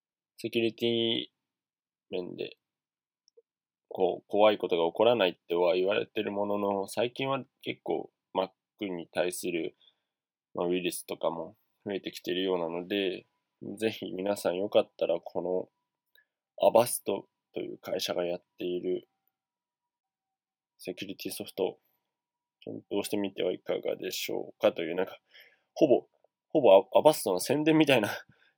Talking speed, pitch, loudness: 290 characters per minute, 115 Hz, -30 LUFS